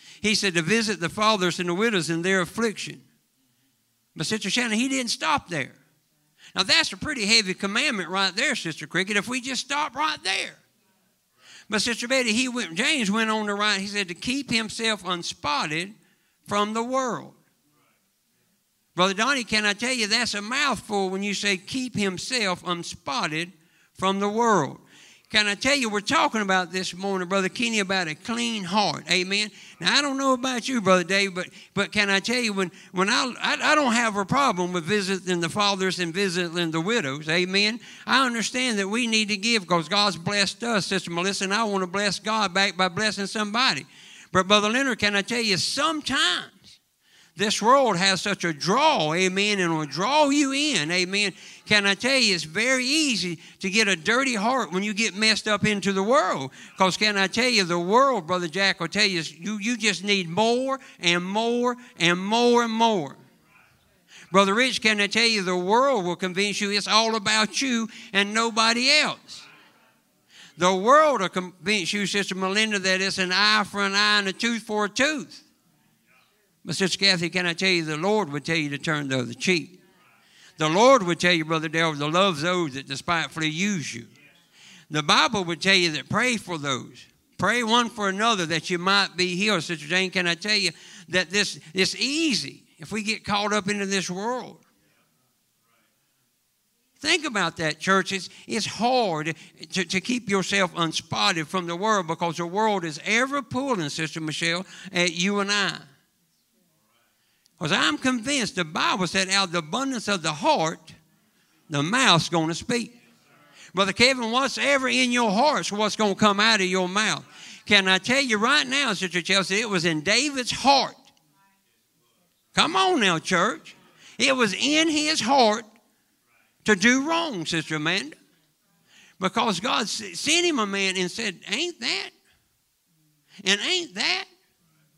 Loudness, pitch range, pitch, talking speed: -23 LUFS, 180-230 Hz, 200 Hz, 185 wpm